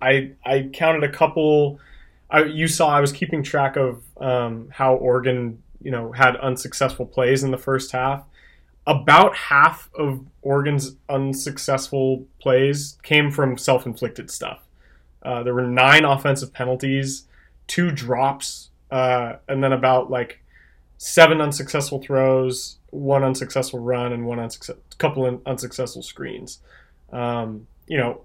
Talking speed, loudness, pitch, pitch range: 135 wpm, -20 LUFS, 130 Hz, 125-140 Hz